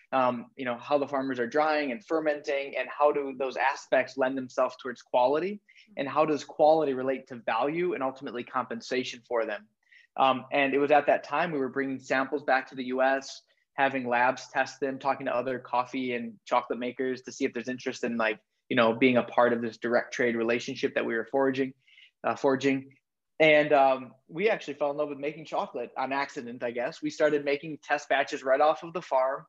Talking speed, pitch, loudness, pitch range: 210 wpm, 135 Hz, -28 LUFS, 125-145 Hz